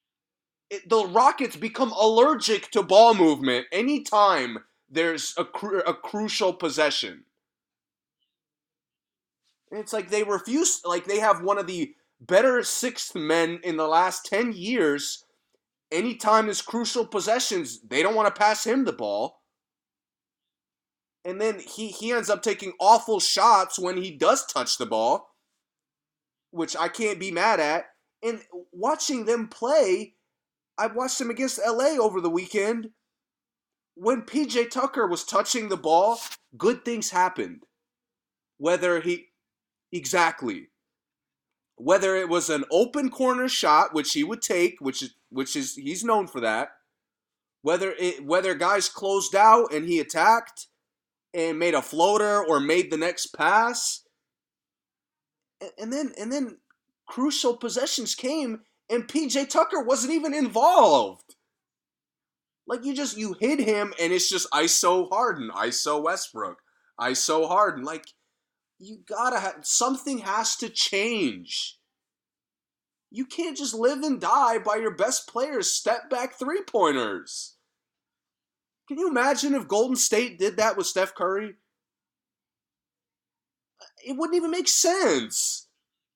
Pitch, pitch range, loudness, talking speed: 220 Hz, 180-255 Hz, -24 LUFS, 135 wpm